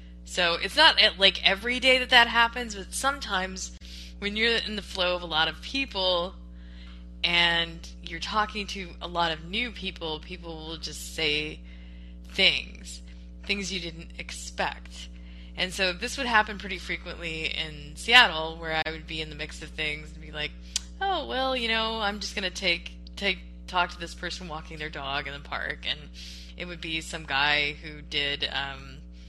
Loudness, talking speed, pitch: -26 LUFS, 180 wpm, 160 Hz